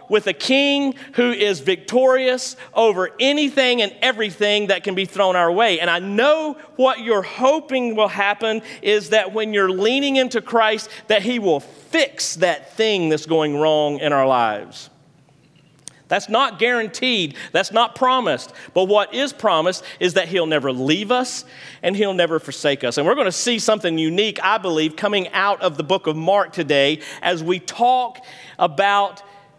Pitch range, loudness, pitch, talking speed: 175-240 Hz, -19 LUFS, 200 Hz, 170 wpm